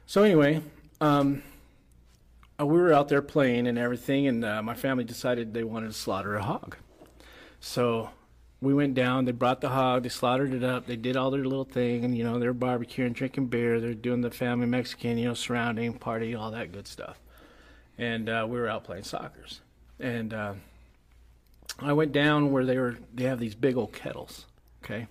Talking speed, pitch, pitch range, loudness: 195 wpm, 120 Hz, 115-130 Hz, -28 LUFS